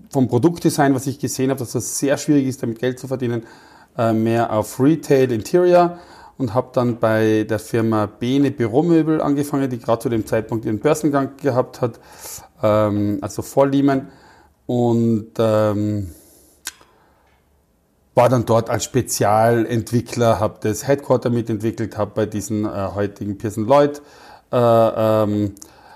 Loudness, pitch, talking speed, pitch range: -19 LUFS, 120 Hz, 145 wpm, 110-135 Hz